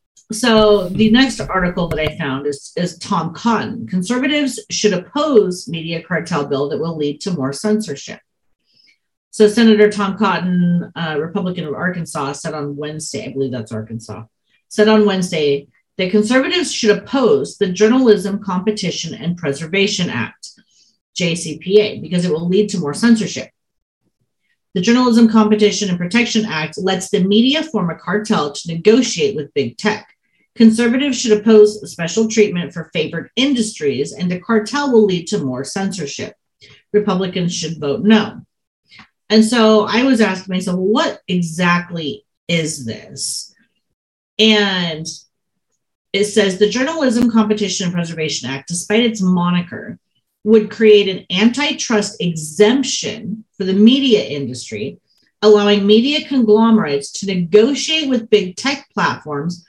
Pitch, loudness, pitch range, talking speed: 200 Hz, -16 LUFS, 165-220 Hz, 135 wpm